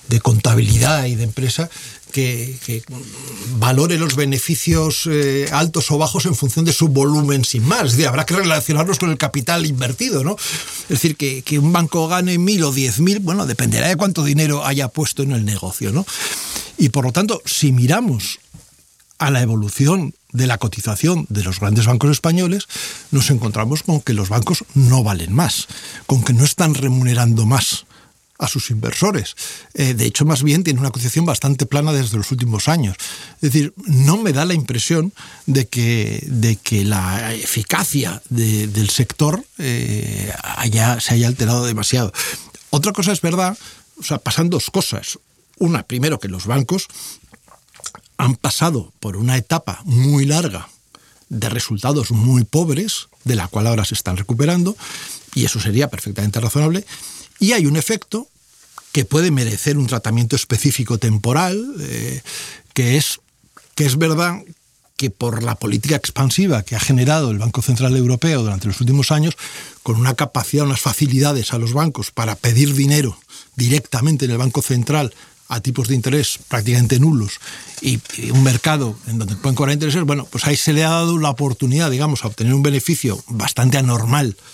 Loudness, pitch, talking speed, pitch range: -17 LUFS, 135 Hz, 170 wpm, 120-155 Hz